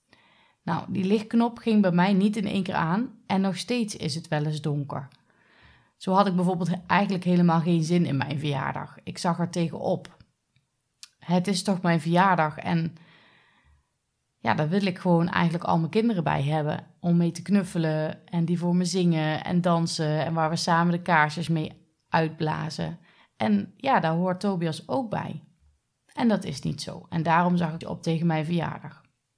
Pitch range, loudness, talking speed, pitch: 160-185 Hz, -25 LUFS, 185 wpm, 170 Hz